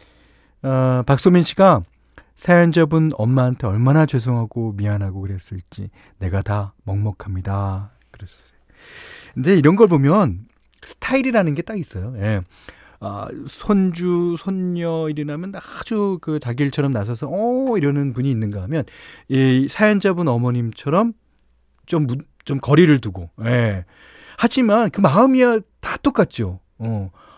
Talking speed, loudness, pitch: 270 characters per minute, -18 LUFS, 135 Hz